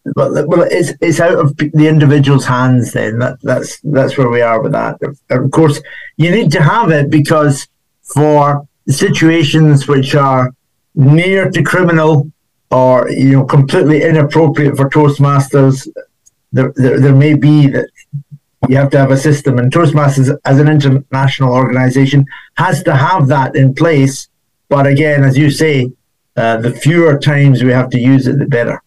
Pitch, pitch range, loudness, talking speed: 140 Hz, 135-150 Hz, -10 LUFS, 165 wpm